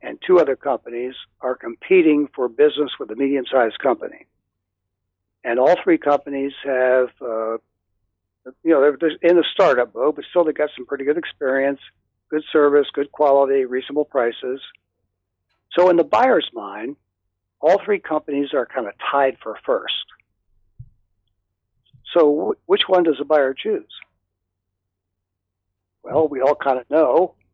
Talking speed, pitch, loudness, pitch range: 145 wpm, 130 Hz, -19 LUFS, 95-150 Hz